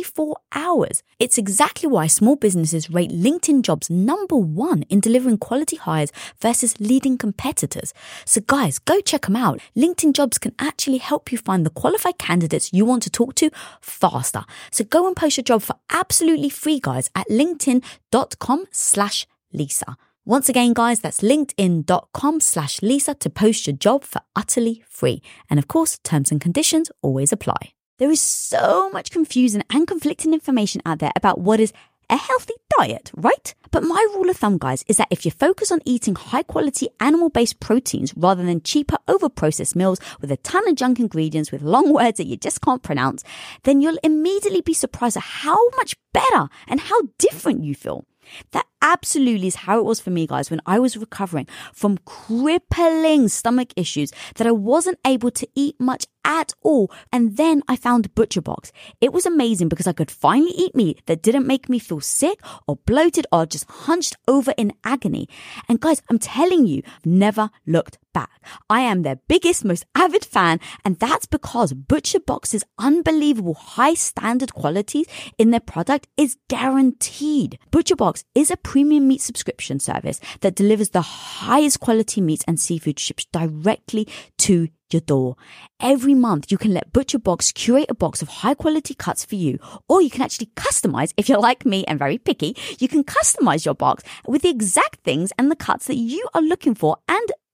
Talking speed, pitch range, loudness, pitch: 185 wpm, 190-295 Hz, -19 LUFS, 240 Hz